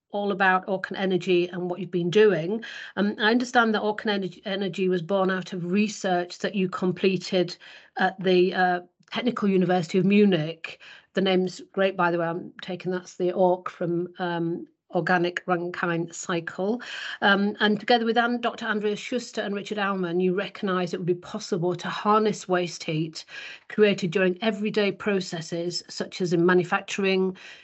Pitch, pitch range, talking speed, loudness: 190 Hz, 180-205 Hz, 165 wpm, -25 LUFS